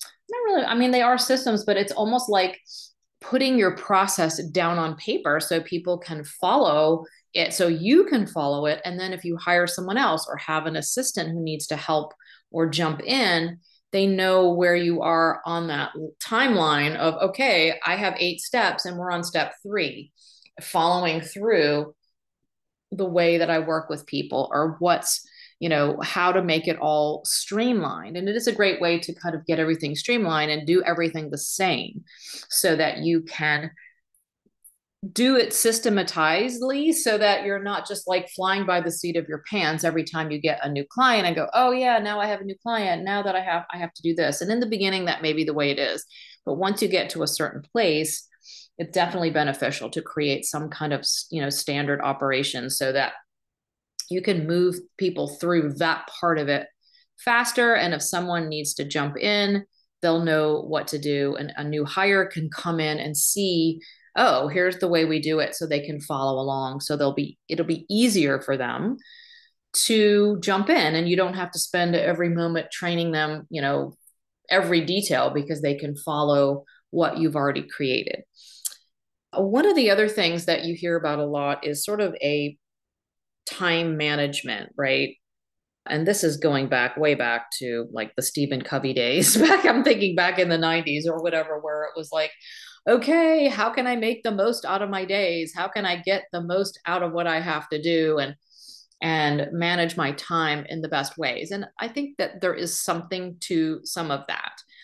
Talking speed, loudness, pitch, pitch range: 195 wpm, -23 LUFS, 170 Hz, 150-195 Hz